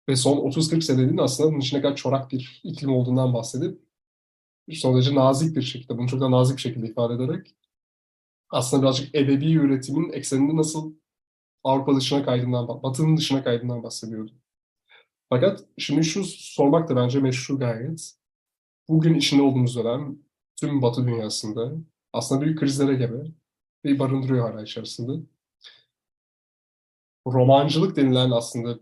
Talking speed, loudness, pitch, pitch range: 135 wpm, -23 LUFS, 135 Hz, 120-145 Hz